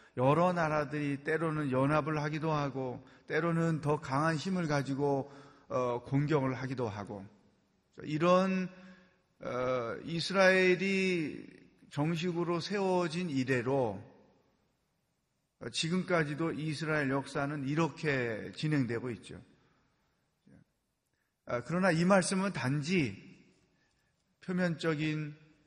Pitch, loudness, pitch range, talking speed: 155 Hz, -32 LUFS, 135-175 Hz, 205 characters per minute